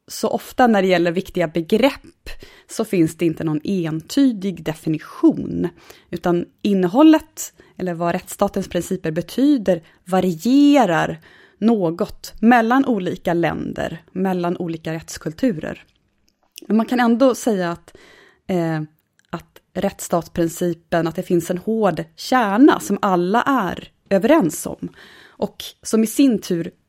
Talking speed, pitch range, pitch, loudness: 120 wpm, 170-240 Hz, 185 Hz, -19 LUFS